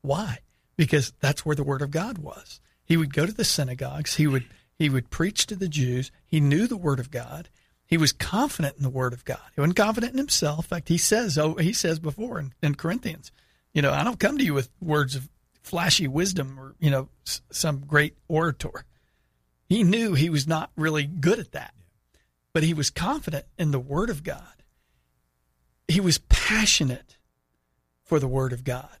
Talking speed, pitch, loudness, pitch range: 205 wpm, 150 Hz, -25 LUFS, 130-165 Hz